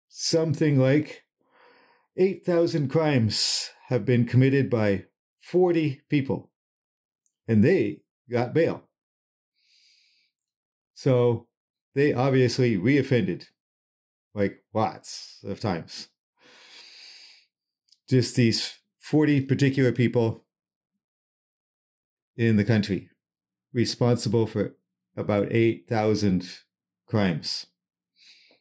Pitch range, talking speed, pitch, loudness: 105-140 Hz, 75 wpm, 120 Hz, -24 LUFS